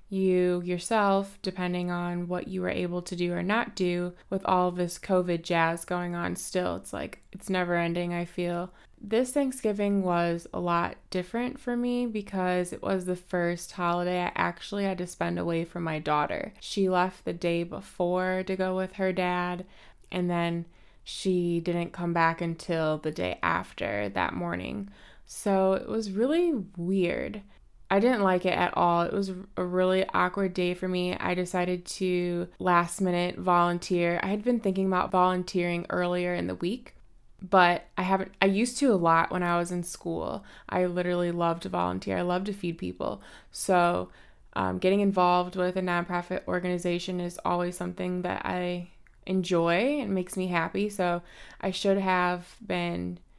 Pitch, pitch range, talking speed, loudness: 180 Hz, 175-190 Hz, 175 wpm, -28 LUFS